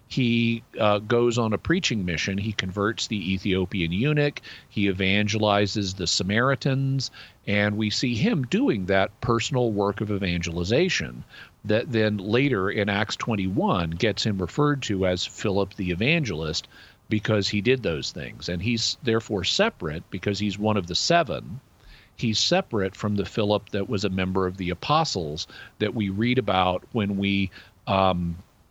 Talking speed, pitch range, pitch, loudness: 155 wpm, 95-115 Hz, 105 Hz, -24 LUFS